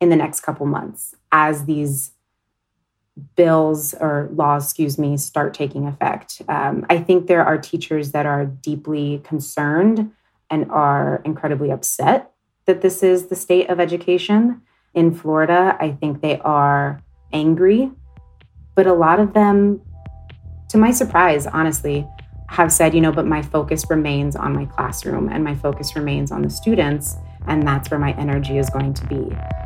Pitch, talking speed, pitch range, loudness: 150 Hz, 160 wpm, 140-170 Hz, -18 LUFS